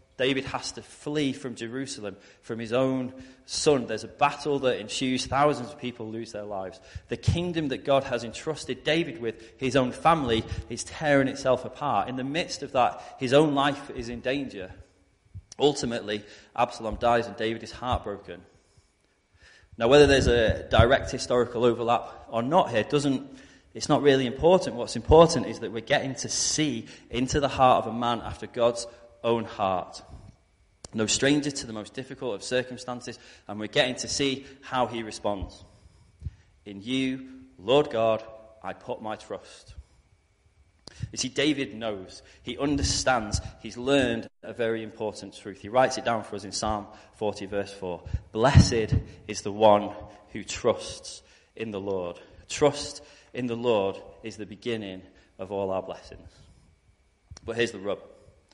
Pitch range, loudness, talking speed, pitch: 105-130 Hz, -26 LUFS, 165 wpm, 115 Hz